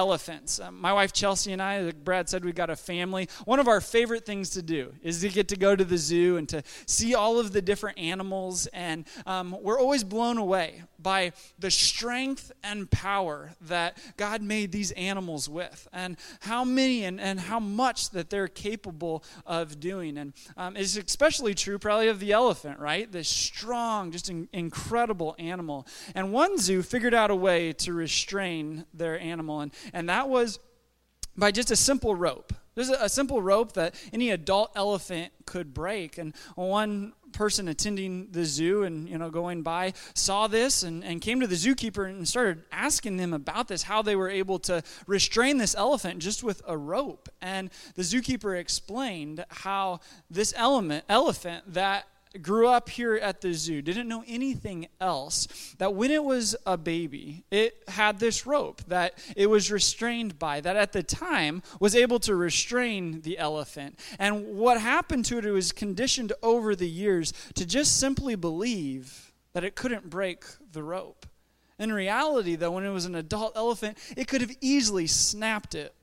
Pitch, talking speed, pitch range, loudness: 195 Hz, 180 wpm, 175-225 Hz, -27 LUFS